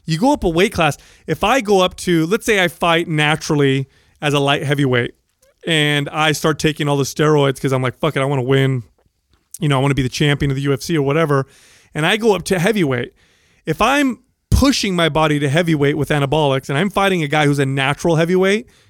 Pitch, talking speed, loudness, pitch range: 155 Hz, 225 wpm, -16 LUFS, 140-175 Hz